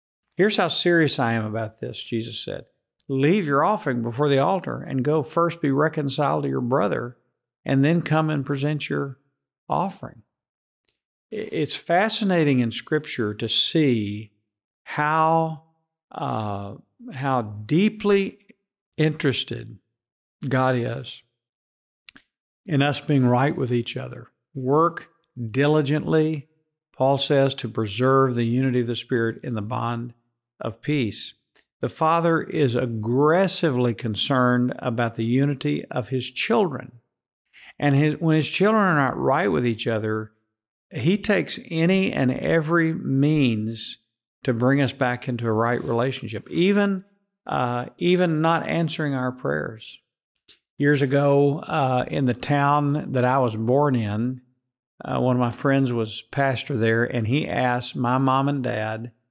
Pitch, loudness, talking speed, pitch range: 135 Hz, -23 LUFS, 135 wpm, 120-155 Hz